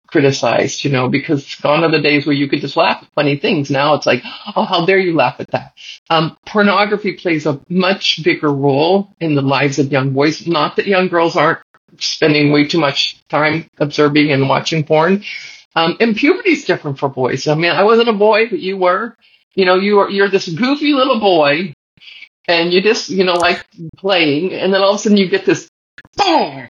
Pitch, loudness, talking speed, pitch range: 170 Hz, -14 LUFS, 215 wpm, 145-195 Hz